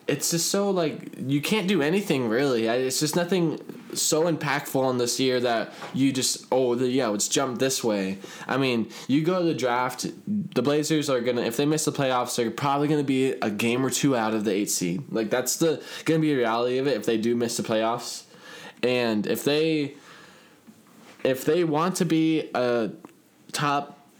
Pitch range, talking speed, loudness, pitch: 120-155 Hz, 205 wpm, -25 LUFS, 135 Hz